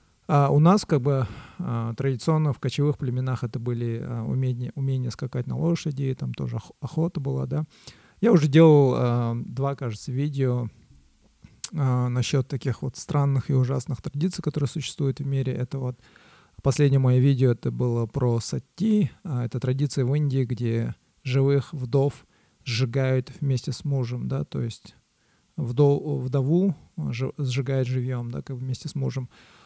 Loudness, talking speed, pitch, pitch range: -25 LUFS, 145 wpm, 130 Hz, 125-140 Hz